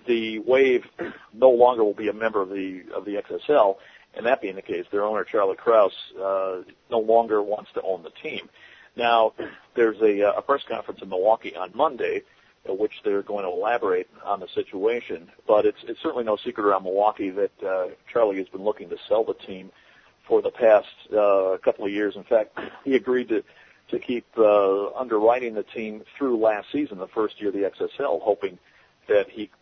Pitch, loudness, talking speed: 130 Hz, -24 LUFS, 195 wpm